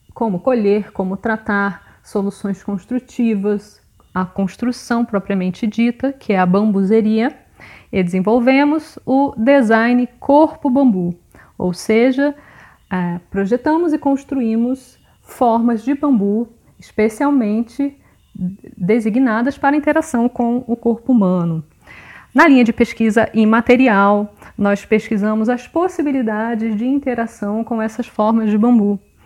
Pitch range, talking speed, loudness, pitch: 205-255 Hz, 105 wpm, -16 LUFS, 230 Hz